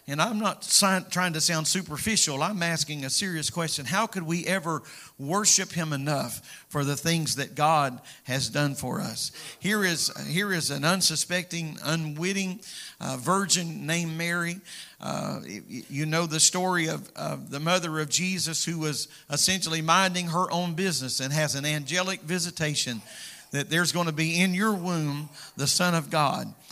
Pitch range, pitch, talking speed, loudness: 150-185 Hz, 165 Hz, 165 wpm, -26 LUFS